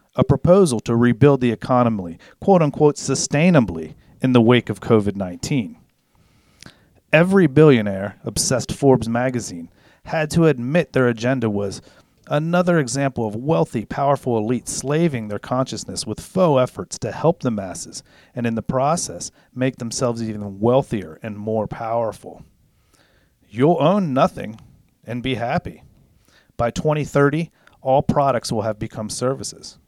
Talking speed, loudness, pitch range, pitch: 135 wpm, -19 LUFS, 110-145 Hz, 125 Hz